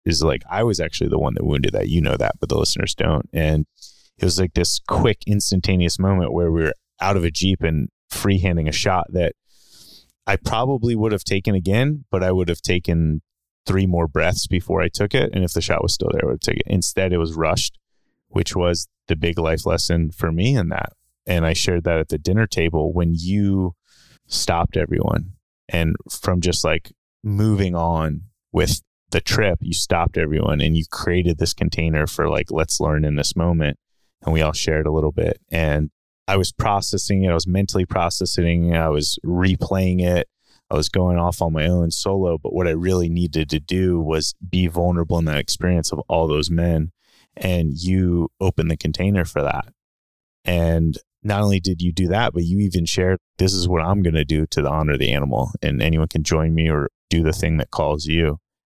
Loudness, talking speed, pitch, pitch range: -20 LUFS, 210 wpm, 85 Hz, 80-95 Hz